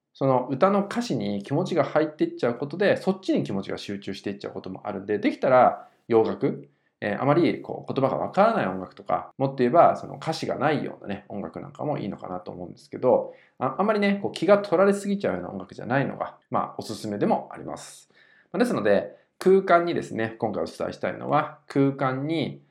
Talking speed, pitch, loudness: 450 characters per minute, 140 Hz, -25 LUFS